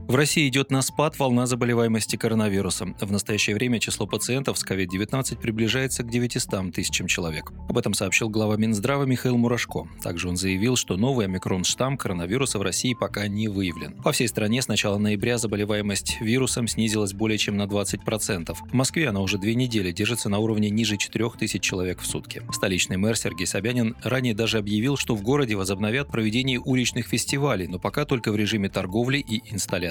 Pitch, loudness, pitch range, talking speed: 110 Hz, -24 LUFS, 100-125 Hz, 175 wpm